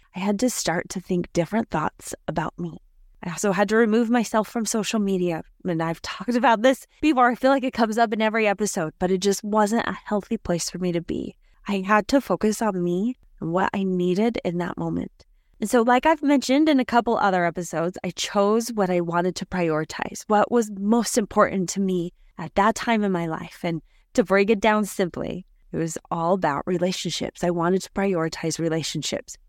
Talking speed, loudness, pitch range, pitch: 210 wpm, -23 LUFS, 175-225 Hz, 200 Hz